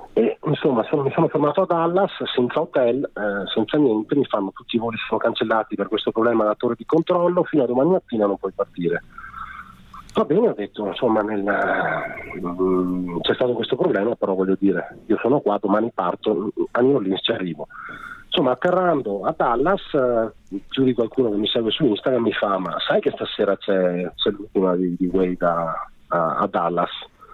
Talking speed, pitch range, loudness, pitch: 190 wpm, 95-140 Hz, -21 LUFS, 110 Hz